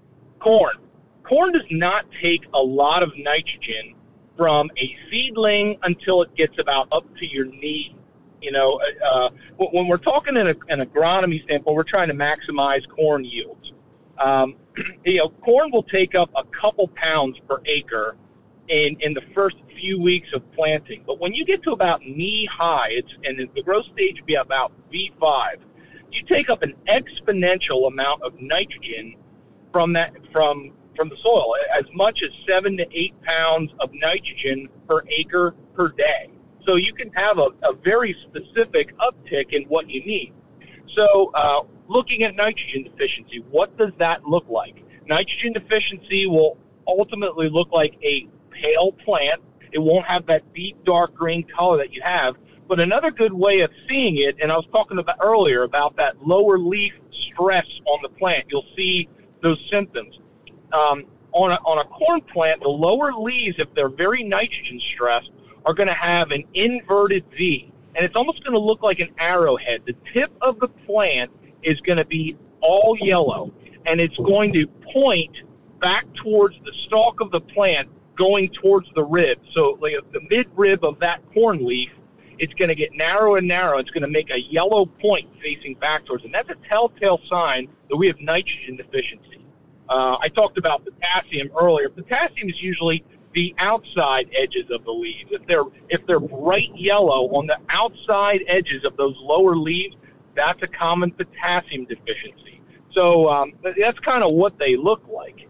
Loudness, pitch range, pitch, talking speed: -20 LUFS, 150-205 Hz, 175 Hz, 175 wpm